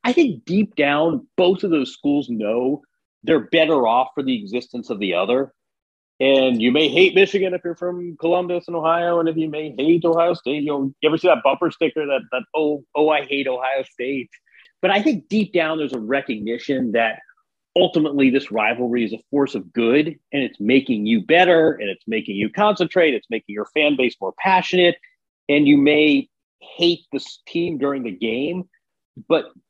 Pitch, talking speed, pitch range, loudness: 155 Hz, 195 wpm, 135-175 Hz, -19 LUFS